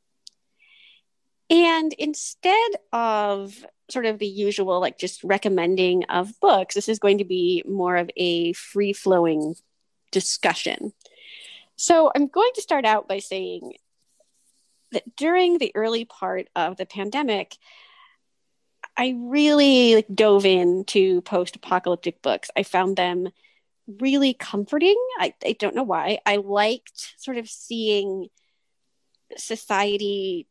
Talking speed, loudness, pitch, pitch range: 120 wpm, -22 LUFS, 205 Hz, 185-275 Hz